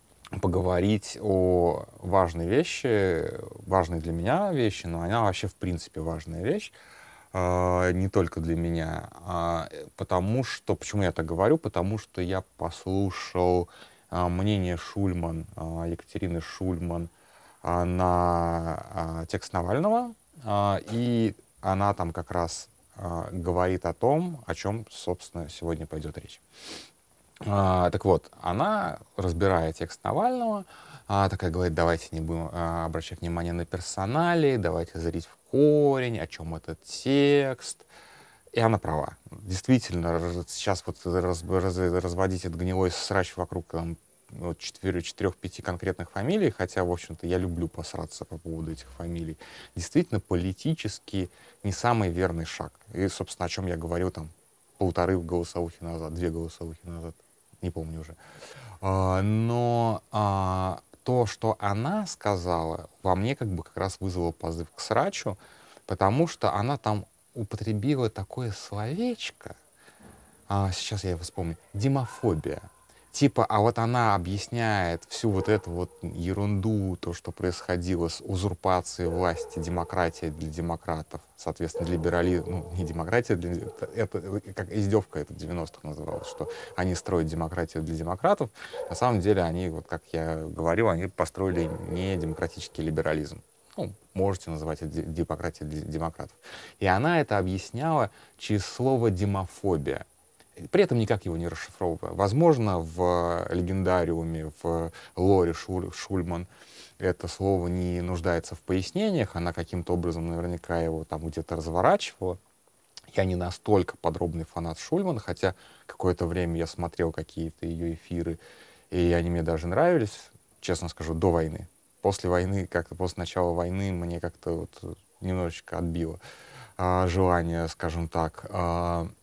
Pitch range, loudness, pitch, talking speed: 85-100 Hz, -29 LUFS, 90 Hz, 130 wpm